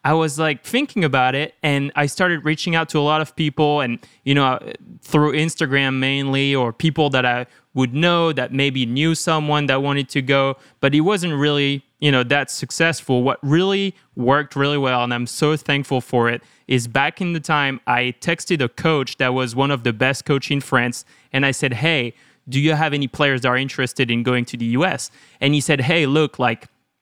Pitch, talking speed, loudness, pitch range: 140 Hz, 215 wpm, -19 LUFS, 130-155 Hz